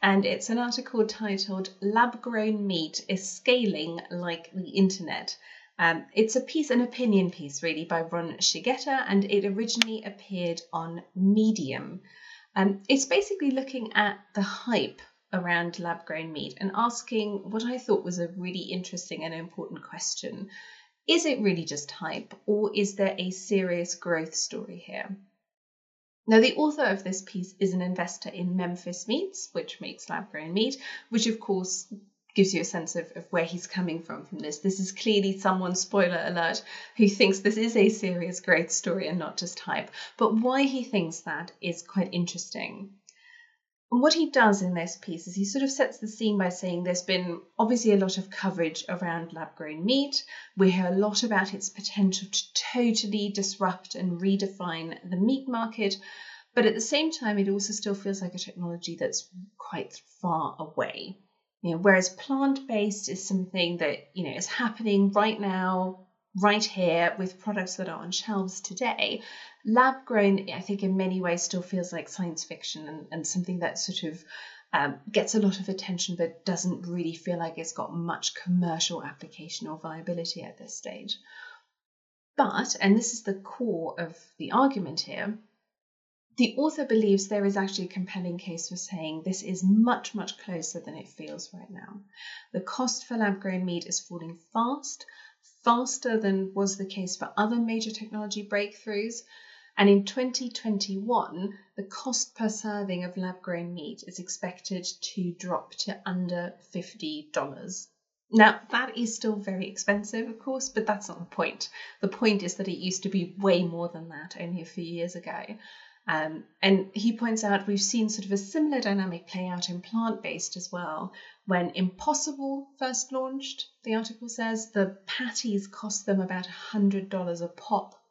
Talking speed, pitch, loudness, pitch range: 175 wpm, 195 Hz, -28 LUFS, 180-225 Hz